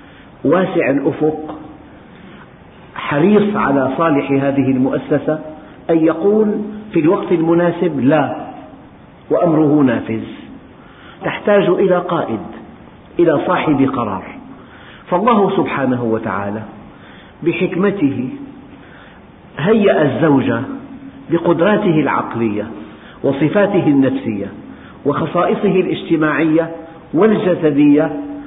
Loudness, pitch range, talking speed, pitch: -15 LUFS, 140-190 Hz, 70 wpm, 165 Hz